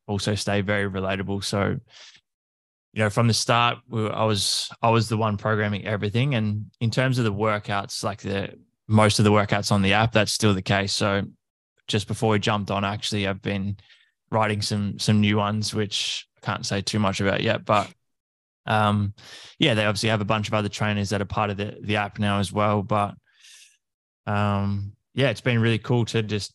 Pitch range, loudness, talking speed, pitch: 100-110 Hz, -24 LUFS, 205 wpm, 105 Hz